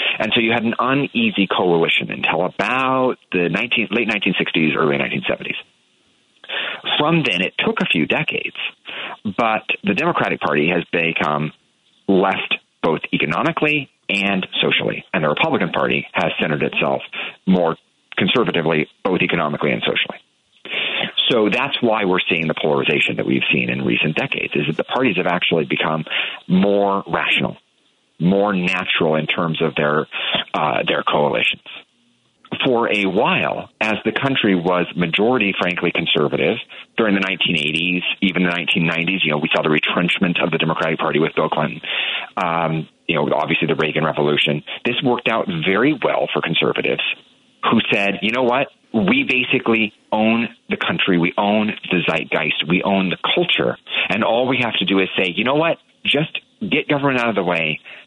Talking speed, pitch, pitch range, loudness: 165 wpm, 95 Hz, 80-115 Hz, -18 LUFS